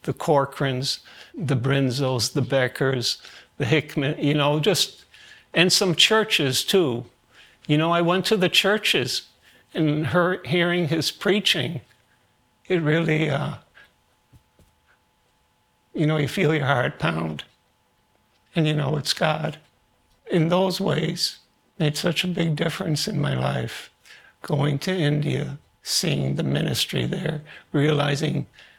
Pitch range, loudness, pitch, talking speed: 135-170 Hz, -22 LUFS, 150 Hz, 125 wpm